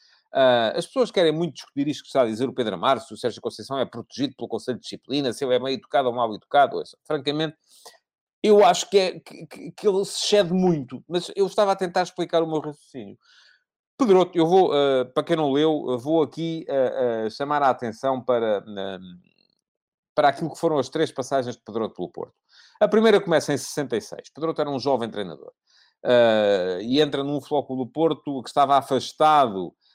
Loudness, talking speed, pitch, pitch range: -23 LUFS, 210 wpm, 145 Hz, 125-170 Hz